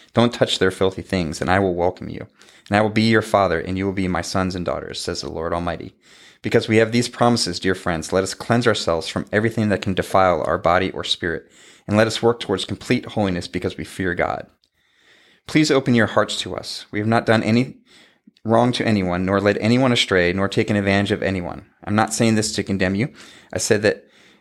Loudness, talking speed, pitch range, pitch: -20 LUFS, 225 wpm, 90-110 Hz, 100 Hz